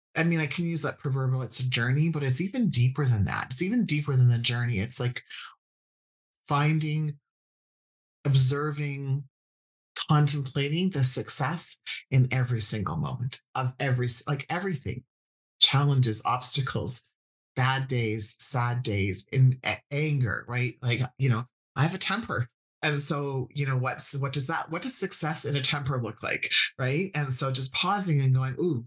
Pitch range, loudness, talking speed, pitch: 125-150 Hz, -26 LUFS, 160 wpm, 135 Hz